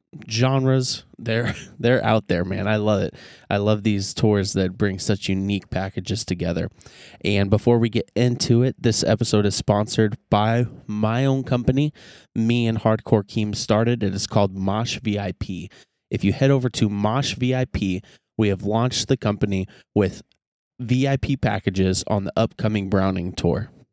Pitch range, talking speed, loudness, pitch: 100-120 Hz, 160 wpm, -22 LUFS, 110 Hz